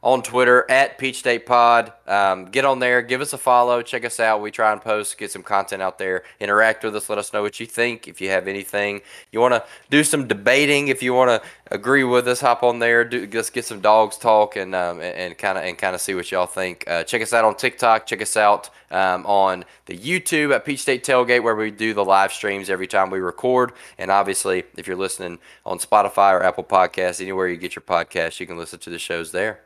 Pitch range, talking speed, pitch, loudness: 95-125 Hz, 245 wpm, 110 Hz, -19 LUFS